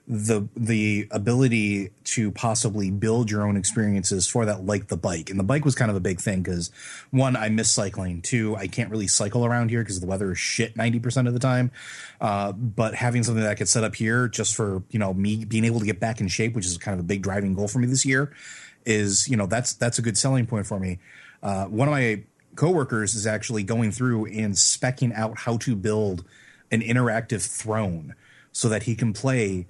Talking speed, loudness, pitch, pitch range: 225 wpm, -24 LUFS, 110 Hz, 100-120 Hz